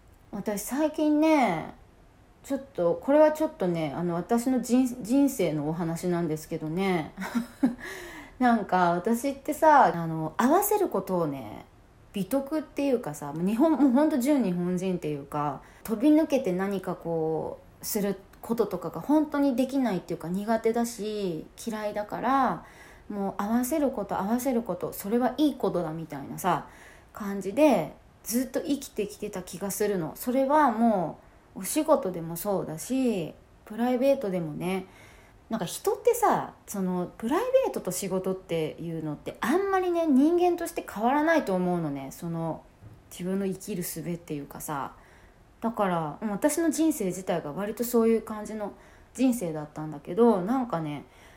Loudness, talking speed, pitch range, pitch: -27 LUFS, 320 characters per minute, 175-270 Hz, 210 Hz